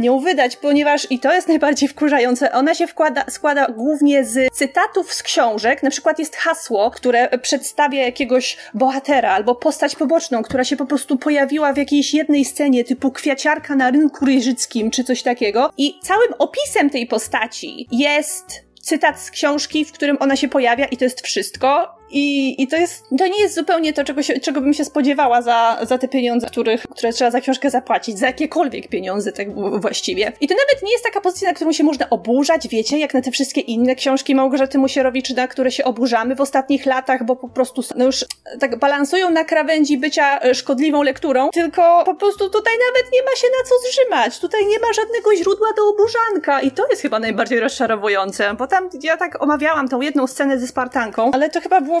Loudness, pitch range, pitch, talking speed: -17 LUFS, 255-320 Hz, 280 Hz, 200 wpm